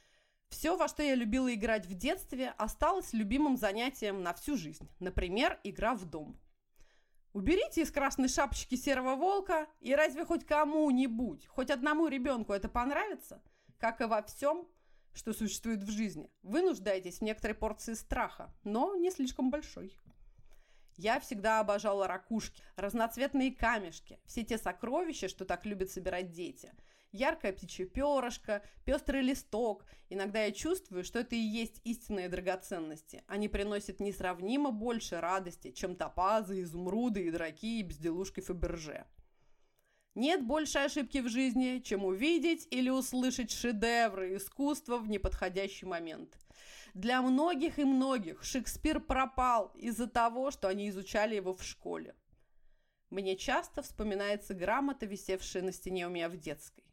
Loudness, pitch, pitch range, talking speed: -35 LUFS, 230 Hz, 195-275 Hz, 140 wpm